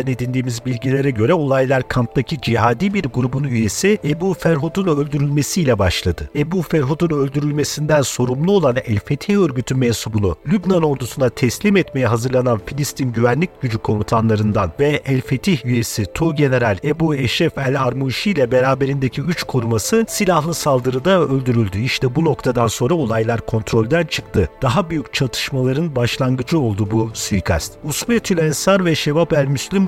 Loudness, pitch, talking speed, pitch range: -18 LUFS, 135 Hz, 135 wpm, 120-160 Hz